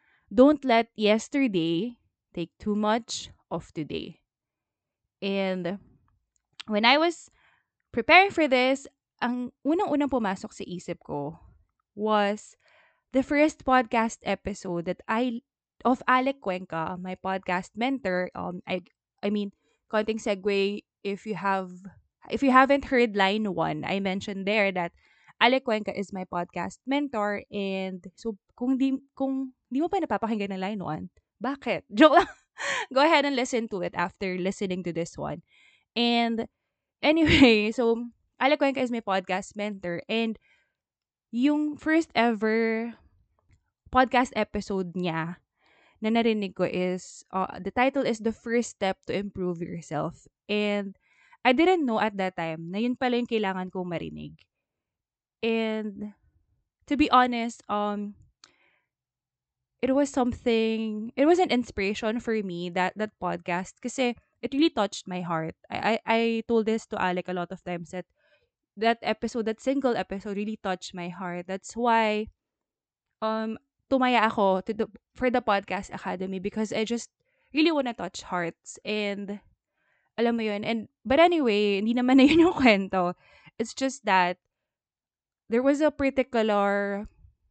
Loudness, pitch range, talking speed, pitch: -26 LUFS, 185-245 Hz, 145 wpm, 215 Hz